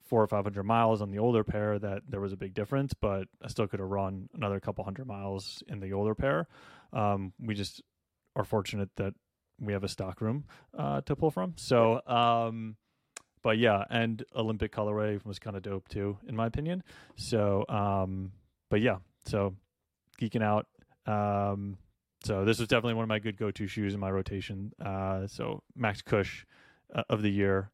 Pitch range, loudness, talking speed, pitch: 100-115 Hz, -32 LUFS, 190 wpm, 105 Hz